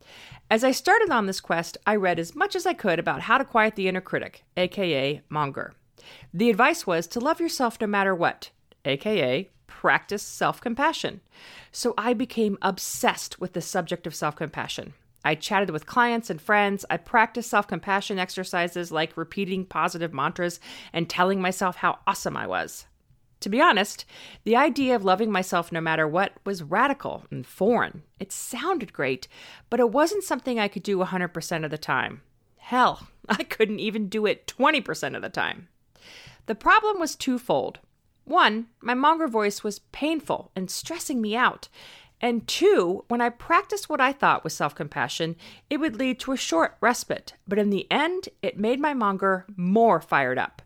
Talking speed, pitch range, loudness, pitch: 175 wpm, 175-250 Hz, -25 LUFS, 205 Hz